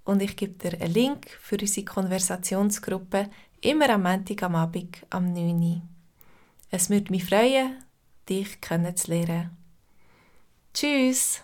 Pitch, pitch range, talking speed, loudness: 190 Hz, 175-205 Hz, 130 wpm, -26 LUFS